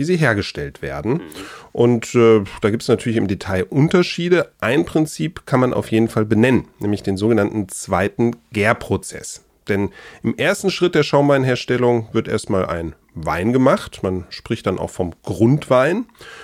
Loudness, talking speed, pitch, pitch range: -18 LUFS, 155 wpm, 115 Hz, 100-140 Hz